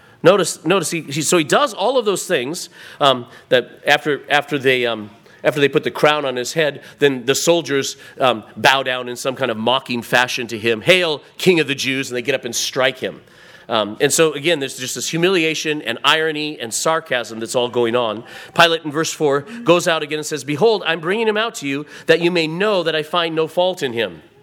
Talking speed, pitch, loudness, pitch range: 230 wpm, 150 Hz, -18 LUFS, 125-165 Hz